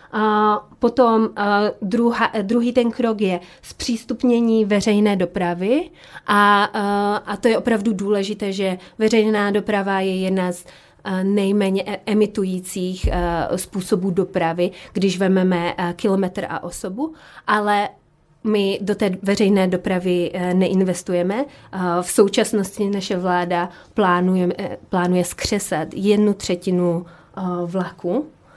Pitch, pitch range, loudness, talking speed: 195 Hz, 180-210 Hz, -20 LUFS, 100 wpm